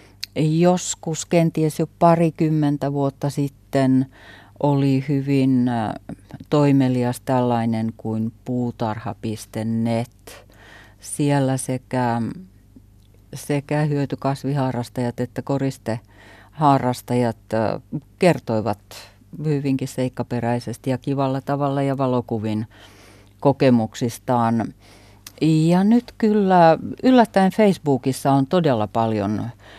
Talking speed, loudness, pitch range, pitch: 70 wpm, -21 LUFS, 110-140 Hz, 125 Hz